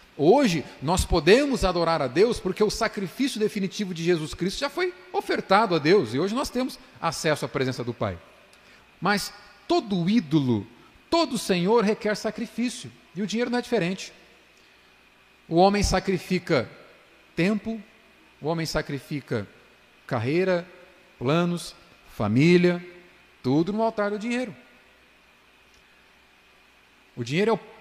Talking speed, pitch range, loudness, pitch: 125 wpm, 165-220 Hz, -25 LUFS, 190 Hz